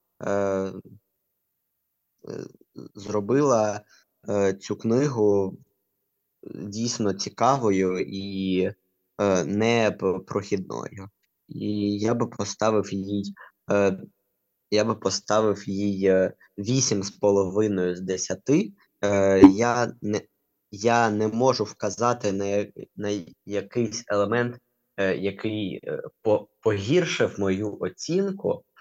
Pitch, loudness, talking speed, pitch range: 100 Hz, -25 LUFS, 70 wpm, 100-110 Hz